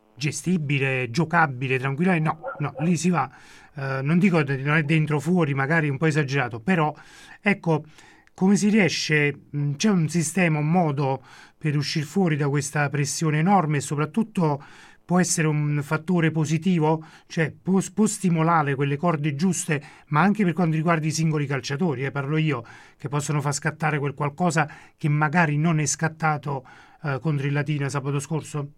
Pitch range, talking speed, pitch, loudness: 145-170 Hz, 175 wpm, 155 Hz, -23 LUFS